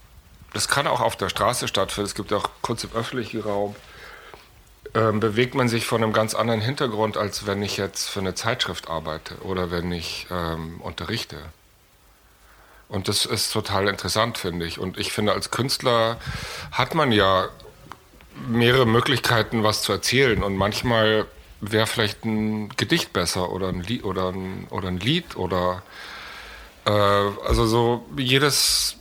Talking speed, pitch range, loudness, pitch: 155 wpm, 95-115 Hz, -23 LUFS, 105 Hz